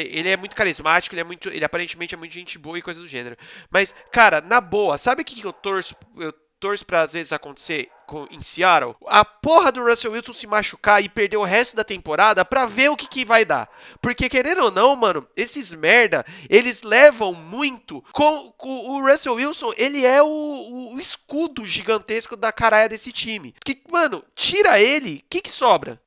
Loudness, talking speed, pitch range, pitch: -19 LUFS, 205 wpm, 190-270 Hz, 225 Hz